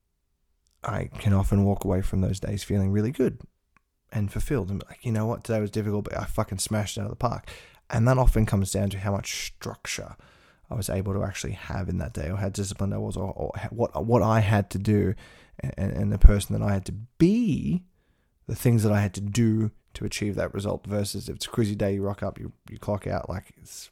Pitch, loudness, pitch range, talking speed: 100 Hz, -27 LUFS, 95-110 Hz, 245 wpm